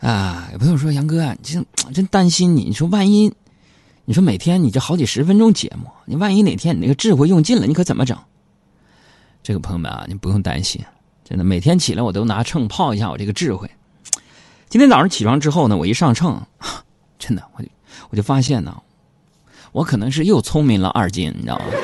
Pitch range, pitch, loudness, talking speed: 105-175 Hz, 140 Hz, -17 LUFS, 315 characters per minute